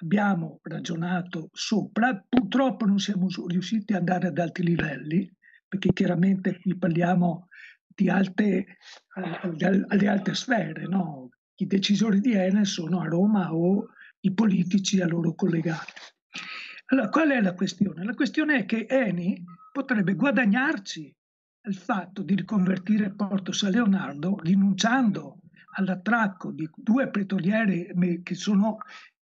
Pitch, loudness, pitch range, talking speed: 195 Hz, -25 LUFS, 180-210 Hz, 130 wpm